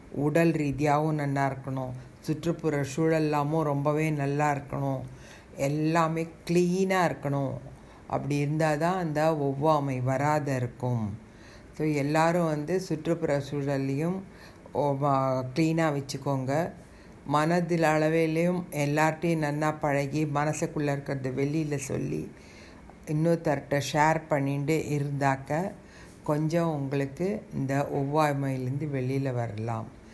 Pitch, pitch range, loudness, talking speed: 150 Hz, 140-160 Hz, -28 LUFS, 90 wpm